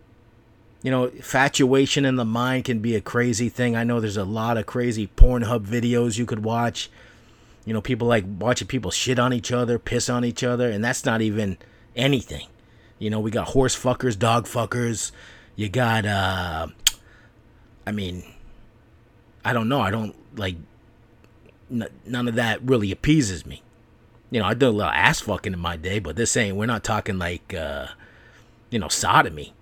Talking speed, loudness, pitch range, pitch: 180 wpm, -23 LUFS, 110-120 Hz, 115 Hz